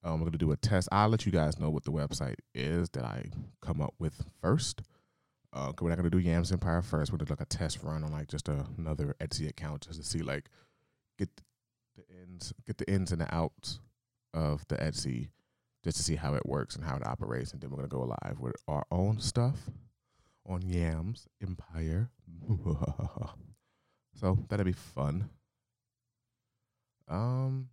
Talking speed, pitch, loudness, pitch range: 190 wpm, 85 Hz, -34 LUFS, 80-115 Hz